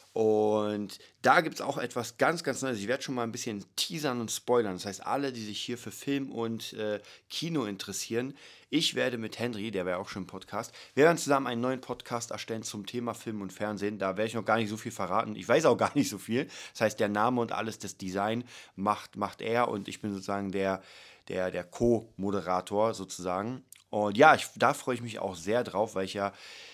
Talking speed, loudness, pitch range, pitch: 230 wpm, -31 LUFS, 100-120 Hz, 110 Hz